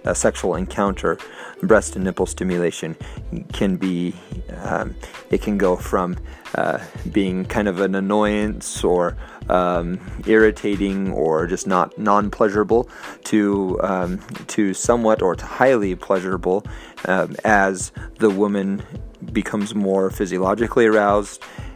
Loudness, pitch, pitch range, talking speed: -20 LUFS, 100 Hz, 95-105 Hz, 120 wpm